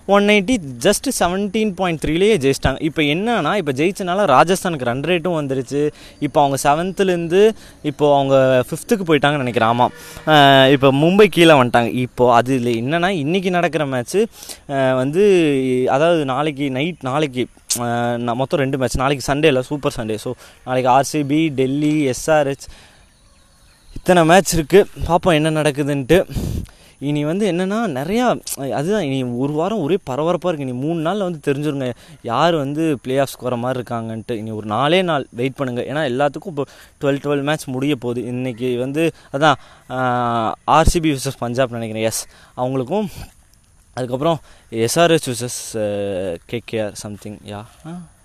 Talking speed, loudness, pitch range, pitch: 140 wpm, -18 LUFS, 125-165 Hz, 140 Hz